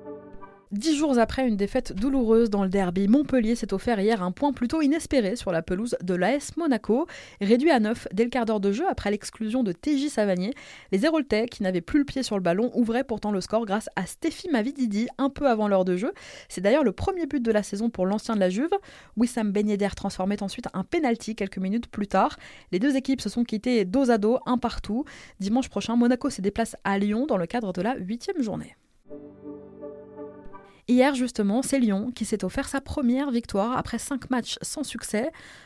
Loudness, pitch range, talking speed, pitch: -25 LUFS, 200-255 Hz, 210 wpm, 230 Hz